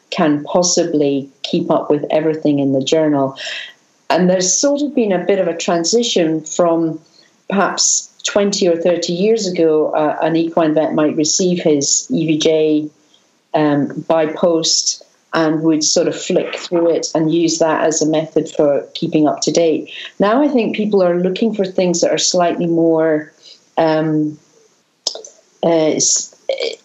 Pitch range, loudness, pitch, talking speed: 155-180 Hz, -15 LUFS, 165 Hz, 155 wpm